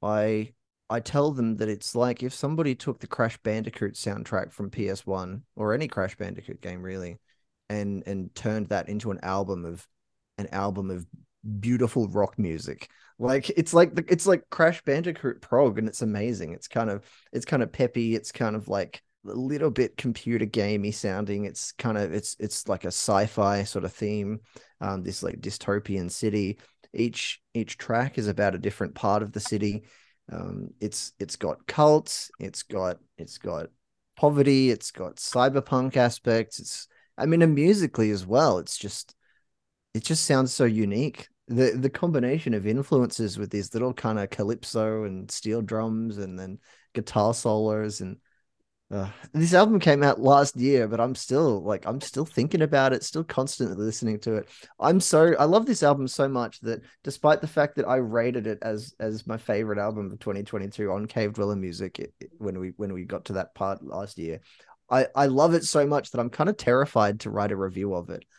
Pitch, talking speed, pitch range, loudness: 110 Hz, 190 wpm, 100-130 Hz, -26 LUFS